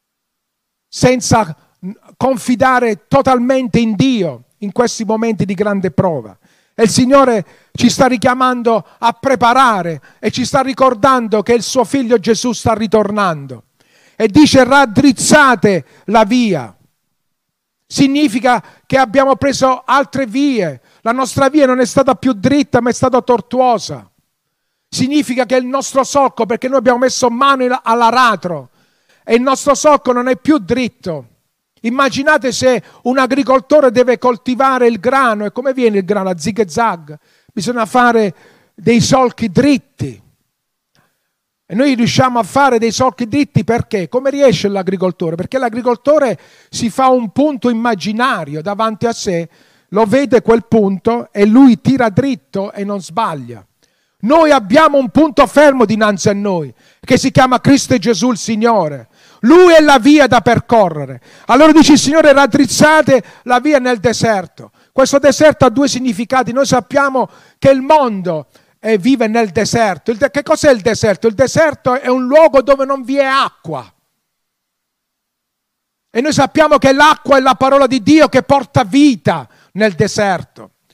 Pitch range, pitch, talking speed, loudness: 215-270 Hz, 245 Hz, 145 wpm, -12 LUFS